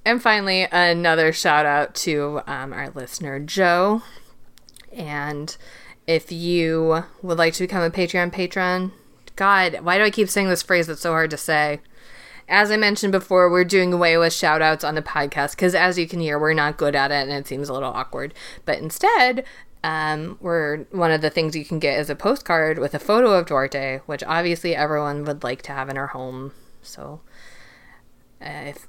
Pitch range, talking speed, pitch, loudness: 150-180 Hz, 195 wpm, 165 Hz, -20 LUFS